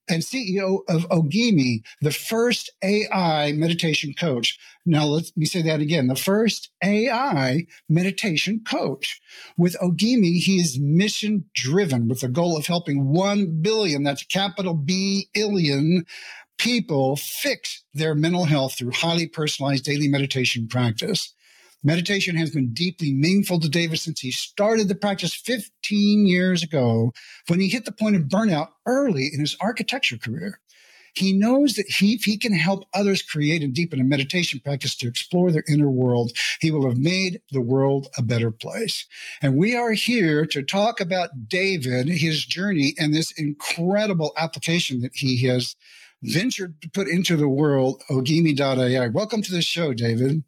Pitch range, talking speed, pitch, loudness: 140-195 Hz, 155 wpm, 165 Hz, -22 LUFS